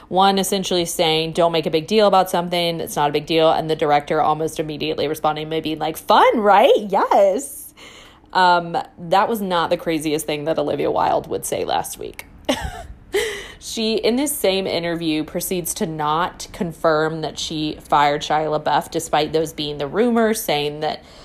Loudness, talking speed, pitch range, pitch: -19 LUFS, 170 wpm, 155-195 Hz, 165 Hz